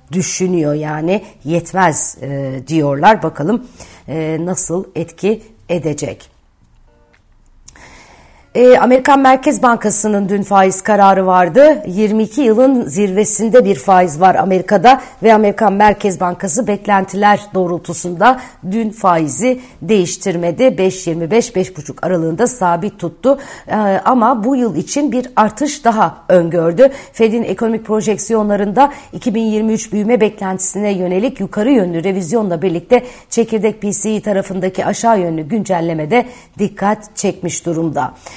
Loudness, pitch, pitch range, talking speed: -13 LUFS, 200 Hz, 175-225 Hz, 105 wpm